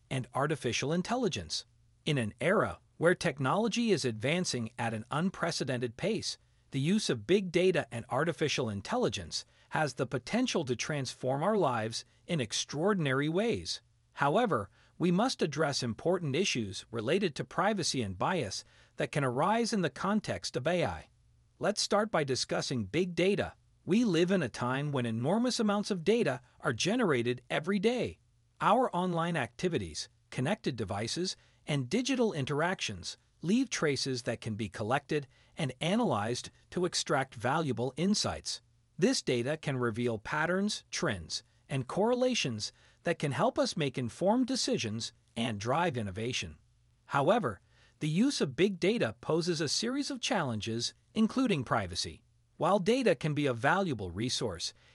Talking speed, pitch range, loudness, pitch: 140 wpm, 120-190 Hz, -32 LUFS, 150 Hz